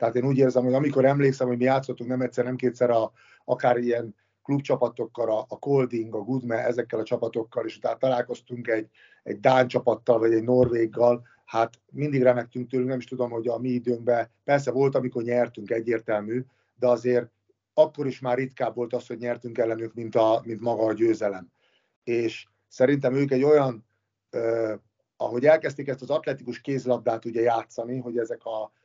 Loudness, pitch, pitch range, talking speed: -25 LUFS, 120 Hz, 115-130 Hz, 180 wpm